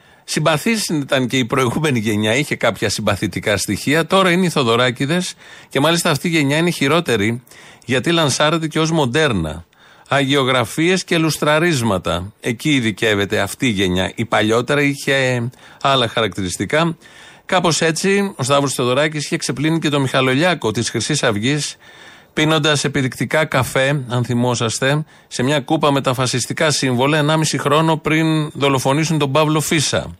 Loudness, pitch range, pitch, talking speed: -17 LUFS, 120-155 Hz, 140 Hz, 140 wpm